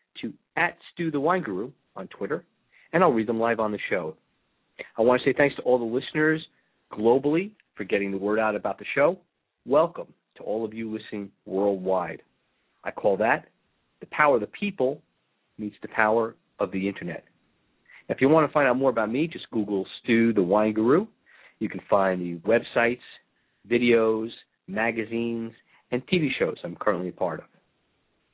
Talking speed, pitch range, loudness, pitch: 180 wpm, 105-125 Hz, -25 LUFS, 115 Hz